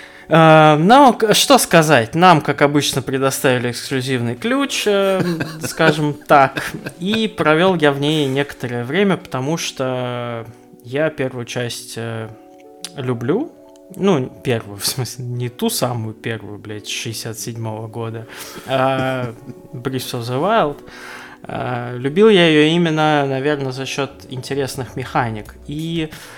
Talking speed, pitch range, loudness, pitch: 115 wpm, 120-160 Hz, -17 LUFS, 135 Hz